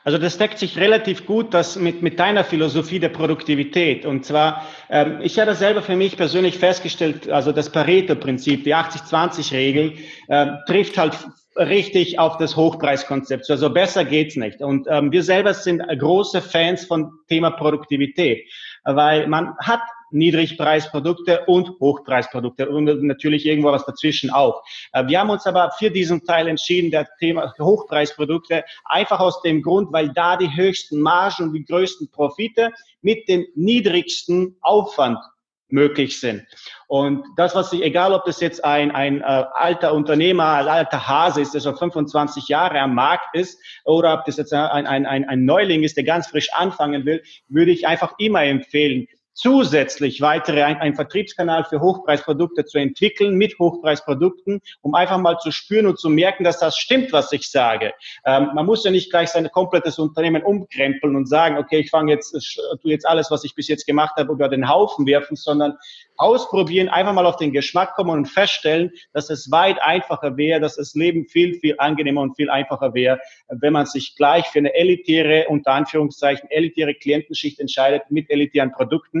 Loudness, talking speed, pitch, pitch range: -18 LUFS, 175 wpm, 155 Hz, 145-180 Hz